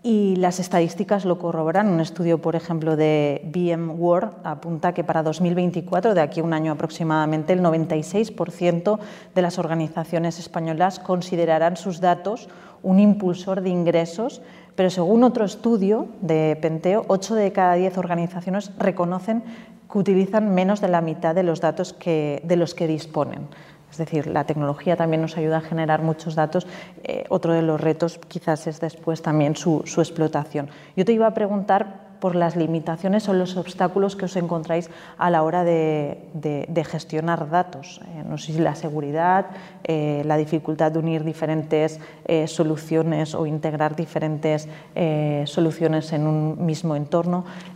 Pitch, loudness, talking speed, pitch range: 170 Hz, -22 LUFS, 160 wpm, 160-185 Hz